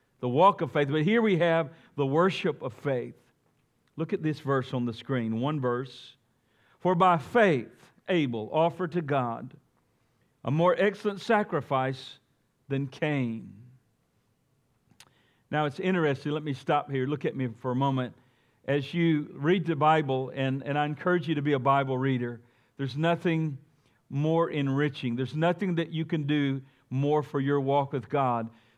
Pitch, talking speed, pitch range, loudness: 140 Hz, 165 wpm, 130-160 Hz, -28 LUFS